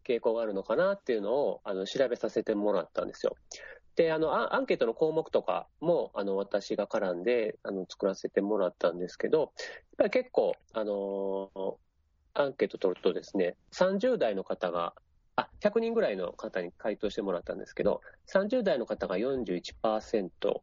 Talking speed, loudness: 340 characters per minute, -31 LUFS